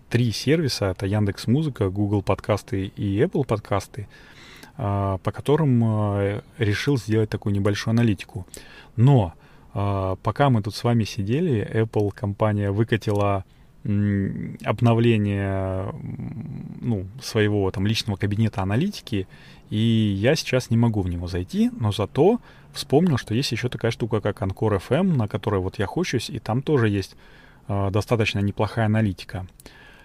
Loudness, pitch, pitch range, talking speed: -23 LUFS, 110 Hz, 100-120 Hz, 130 wpm